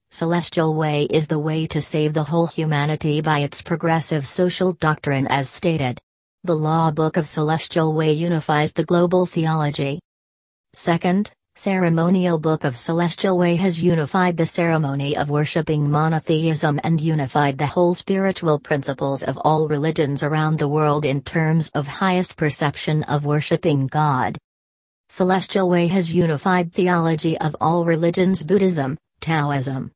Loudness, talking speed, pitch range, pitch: -19 LUFS, 140 wpm, 150-170 Hz, 160 Hz